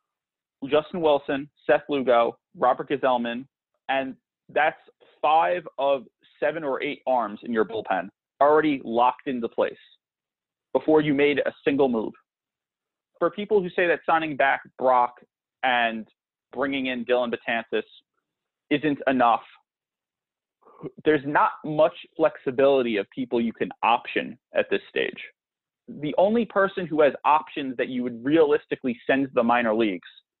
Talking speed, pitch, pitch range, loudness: 135 wpm, 140 Hz, 125-155 Hz, -24 LUFS